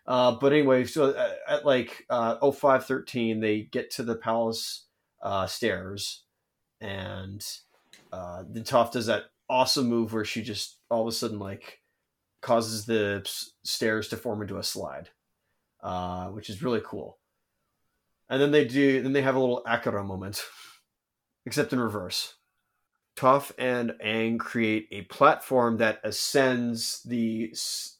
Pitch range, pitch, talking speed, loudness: 105-130 Hz, 115 Hz, 155 wpm, -27 LUFS